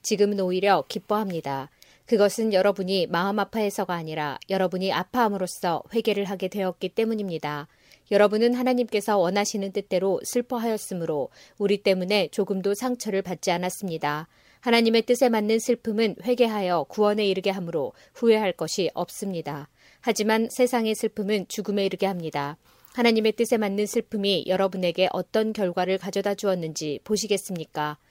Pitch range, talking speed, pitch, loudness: 180-220 Hz, 380 characters per minute, 200 Hz, -25 LUFS